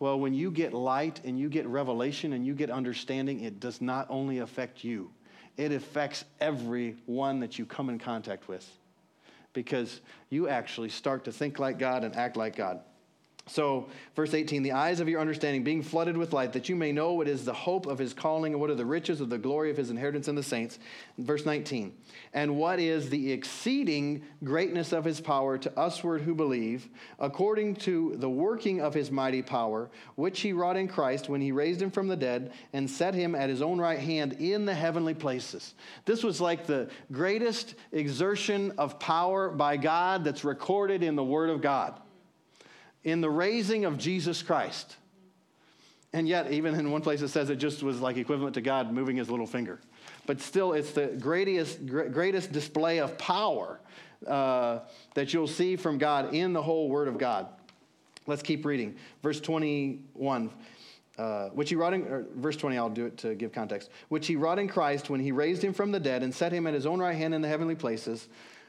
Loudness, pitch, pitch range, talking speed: -31 LUFS, 150 Hz, 135-165 Hz, 200 wpm